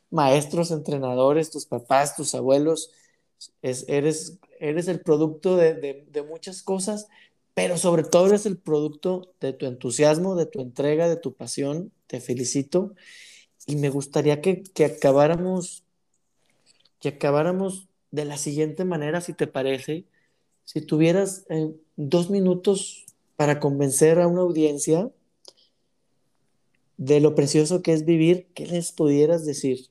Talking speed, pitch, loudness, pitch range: 135 wpm, 155 Hz, -23 LUFS, 145-180 Hz